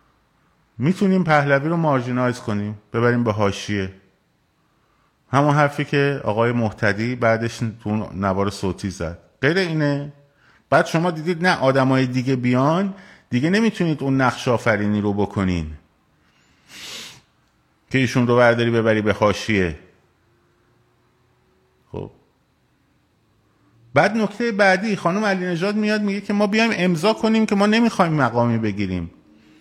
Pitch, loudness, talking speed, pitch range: 125 Hz, -20 LUFS, 120 wpm, 105-170 Hz